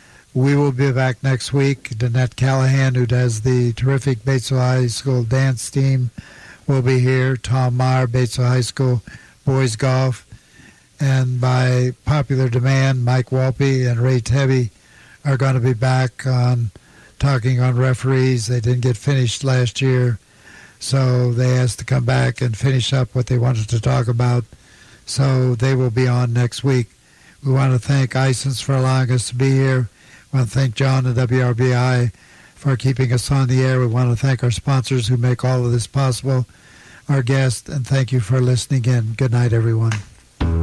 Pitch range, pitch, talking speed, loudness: 125-135 Hz, 130 Hz, 180 wpm, -18 LUFS